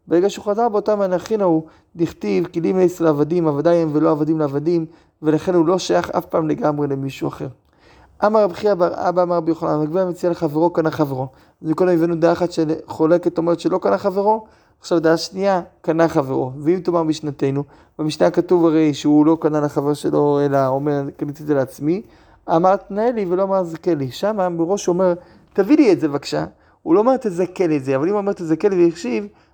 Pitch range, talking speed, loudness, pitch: 155-185 Hz, 170 wpm, -19 LUFS, 170 Hz